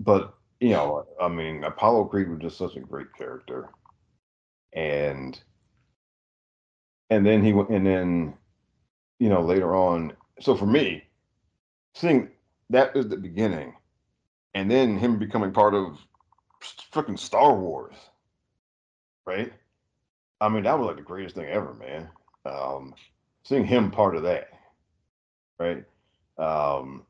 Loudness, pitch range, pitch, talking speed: -24 LUFS, 70-105 Hz, 90 Hz, 135 wpm